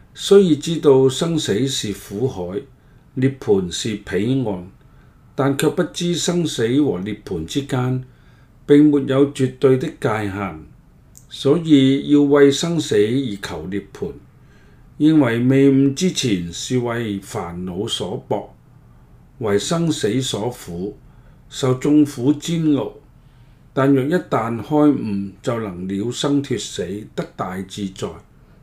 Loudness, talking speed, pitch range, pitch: -19 LUFS, 170 characters per minute, 115-145 Hz, 135 Hz